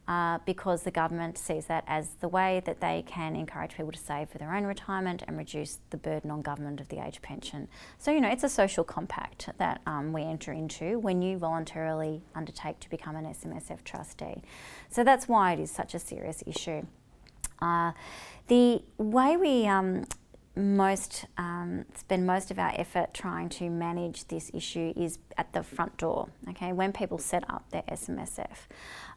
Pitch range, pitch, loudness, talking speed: 155-195 Hz, 170 Hz, -31 LUFS, 185 wpm